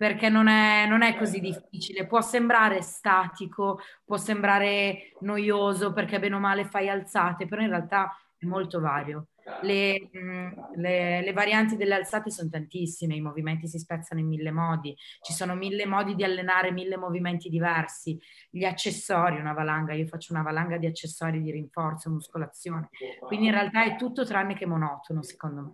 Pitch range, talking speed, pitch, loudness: 165-200 Hz, 170 wpm, 185 Hz, -27 LUFS